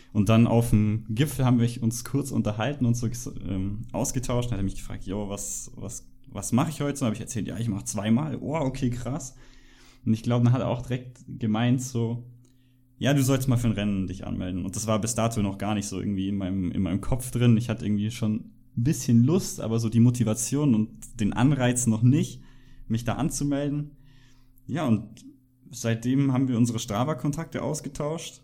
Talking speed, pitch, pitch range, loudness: 205 wpm, 120 Hz, 110-130 Hz, -26 LUFS